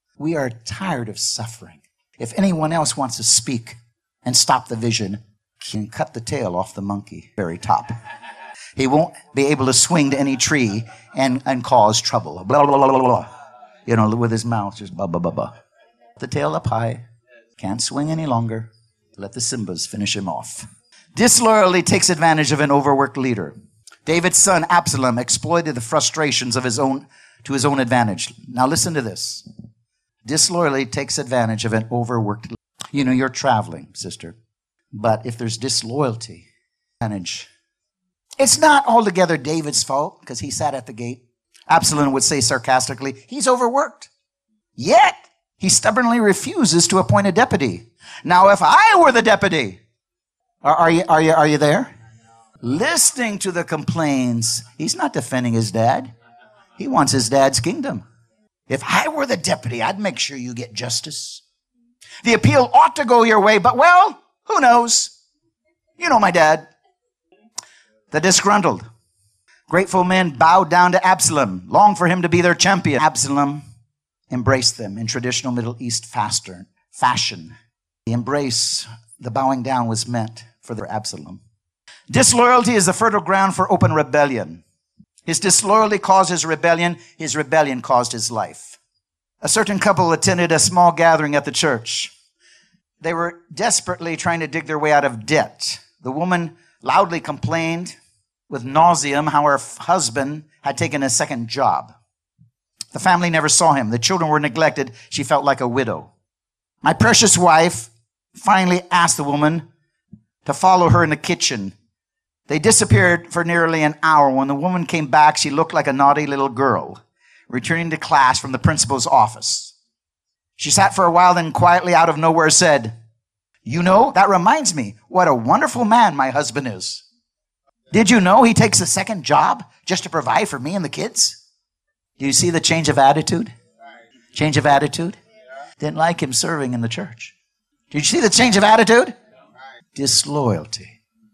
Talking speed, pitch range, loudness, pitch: 165 wpm, 120-175 Hz, -16 LUFS, 145 Hz